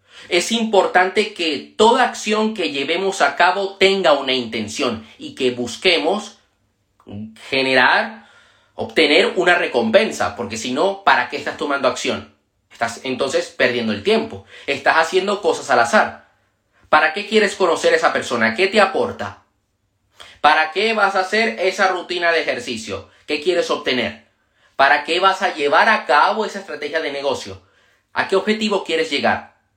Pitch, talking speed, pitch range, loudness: 170 Hz, 150 wpm, 130-200 Hz, -17 LUFS